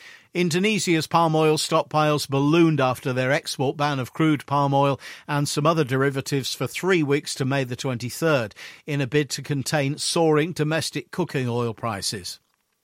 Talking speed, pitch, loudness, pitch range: 160 wpm, 145 Hz, -23 LUFS, 135-160 Hz